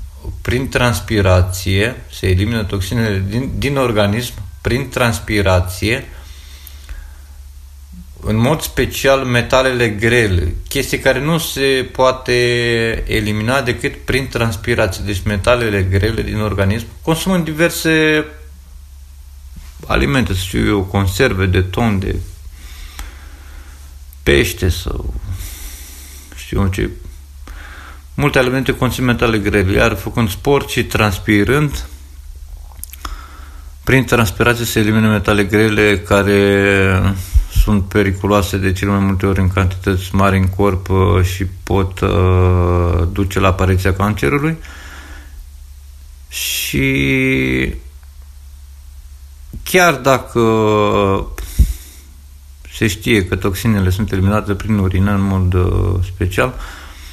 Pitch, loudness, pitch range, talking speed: 95 Hz, -15 LUFS, 70-110 Hz, 100 wpm